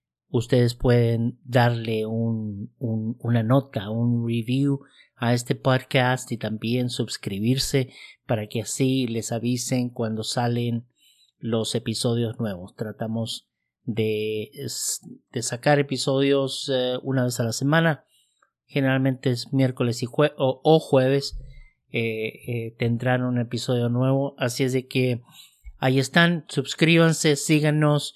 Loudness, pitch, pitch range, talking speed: -24 LUFS, 125 Hz, 115-135 Hz, 125 wpm